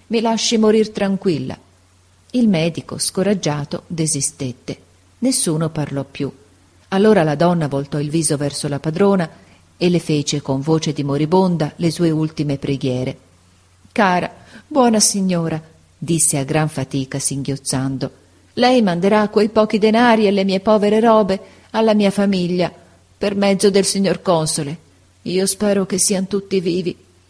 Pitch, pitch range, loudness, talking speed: 170 Hz, 140-200 Hz, -17 LUFS, 140 wpm